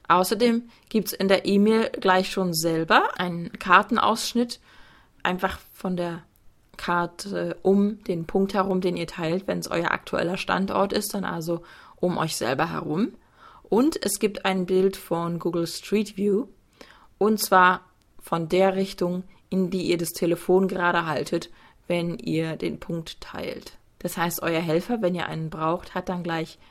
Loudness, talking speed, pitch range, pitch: -25 LUFS, 160 wpm, 170-195 Hz, 180 Hz